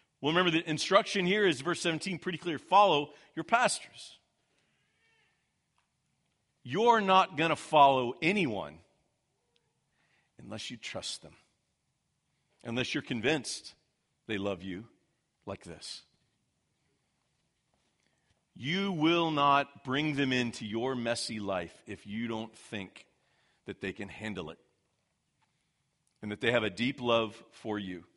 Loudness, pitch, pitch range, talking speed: -30 LUFS, 140 Hz, 115-165 Hz, 125 wpm